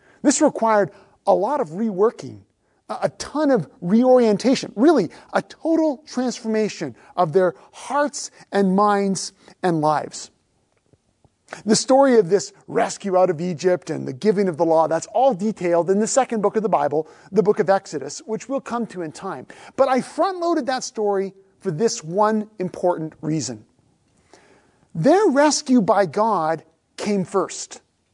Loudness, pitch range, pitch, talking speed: -20 LUFS, 180-250 Hz, 205 Hz, 155 wpm